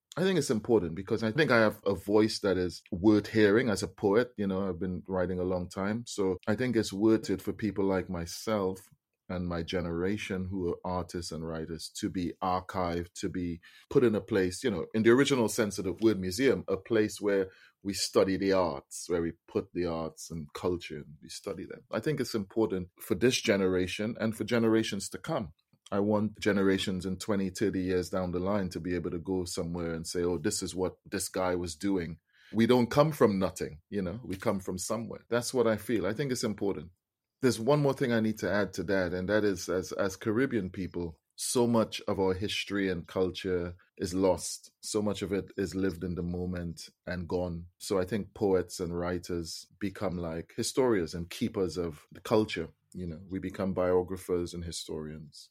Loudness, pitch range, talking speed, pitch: -31 LUFS, 90-105 Hz, 210 wpm, 95 Hz